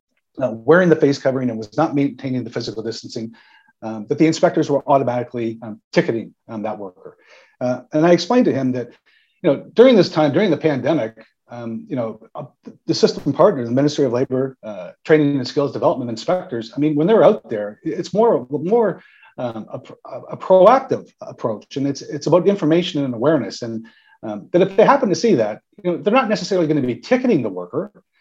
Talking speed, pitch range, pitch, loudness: 205 wpm, 120-170 Hz, 140 Hz, -18 LUFS